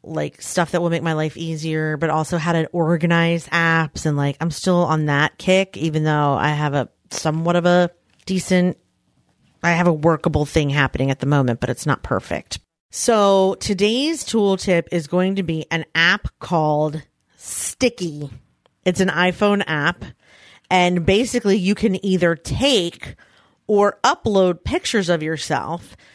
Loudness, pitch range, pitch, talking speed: -19 LUFS, 155-185 Hz, 170 Hz, 160 wpm